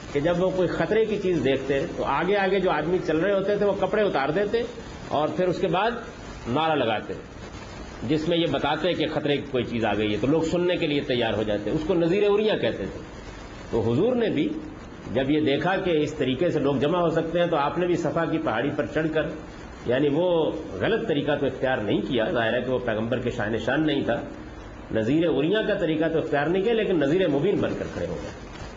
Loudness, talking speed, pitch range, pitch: -24 LUFS, 240 wpm, 140-180 Hz, 160 Hz